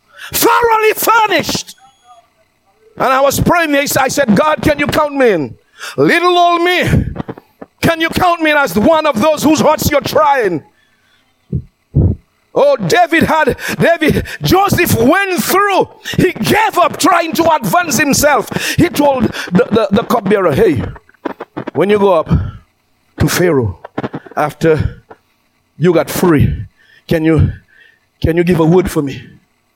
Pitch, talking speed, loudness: 280 Hz, 140 wpm, -12 LUFS